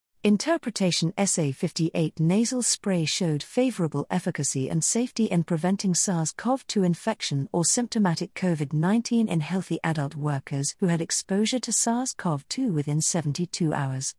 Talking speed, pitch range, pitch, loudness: 145 wpm, 160-215 Hz, 175 Hz, -25 LUFS